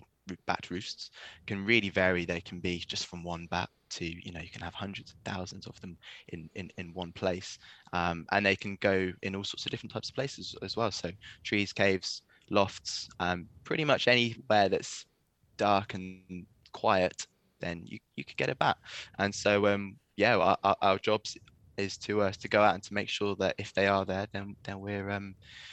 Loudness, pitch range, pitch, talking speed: -31 LUFS, 90-100 Hz, 95 Hz, 210 wpm